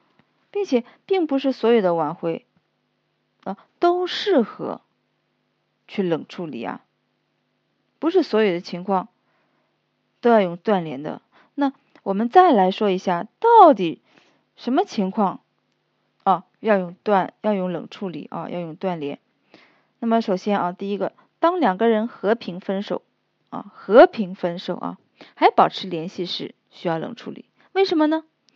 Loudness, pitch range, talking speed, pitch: -21 LUFS, 185-270 Hz, 205 characters per minute, 210 Hz